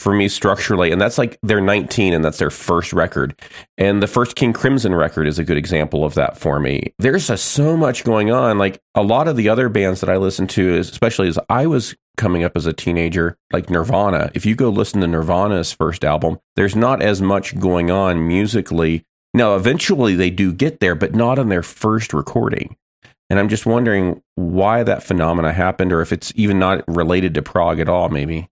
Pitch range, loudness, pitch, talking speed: 85-110 Hz, -17 LUFS, 95 Hz, 215 wpm